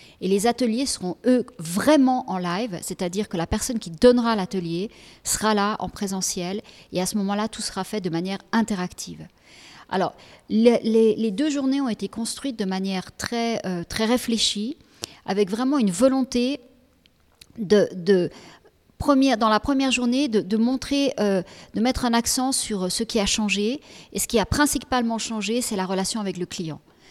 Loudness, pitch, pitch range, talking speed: -23 LUFS, 220 Hz, 195-245 Hz, 175 wpm